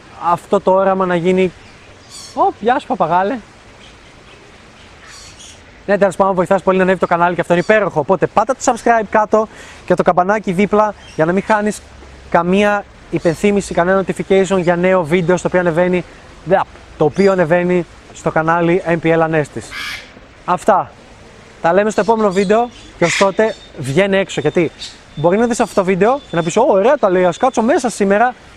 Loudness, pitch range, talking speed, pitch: -15 LUFS, 175-205 Hz, 170 wpm, 190 Hz